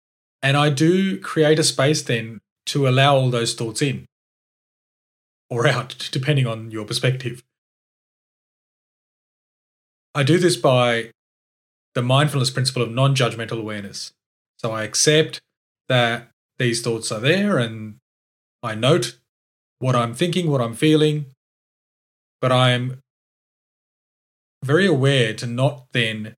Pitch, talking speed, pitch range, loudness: 125 Hz, 125 wpm, 115-145 Hz, -20 LUFS